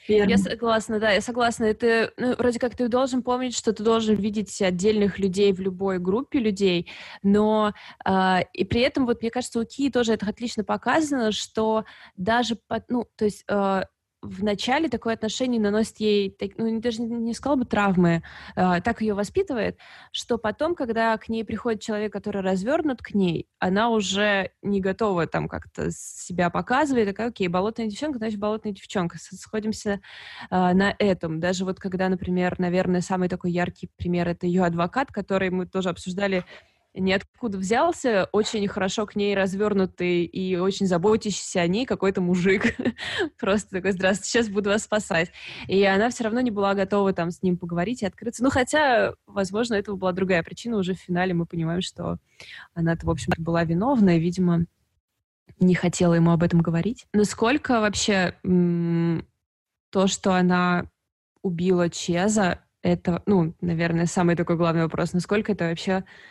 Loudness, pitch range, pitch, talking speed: -24 LUFS, 180-225 Hz, 200 Hz, 170 wpm